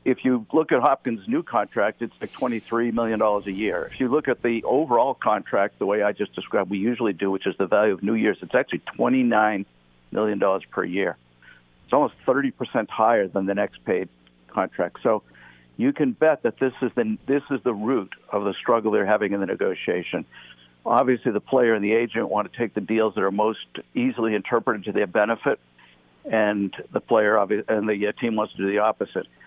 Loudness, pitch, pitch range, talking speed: -23 LUFS, 110 Hz, 100-120 Hz, 210 wpm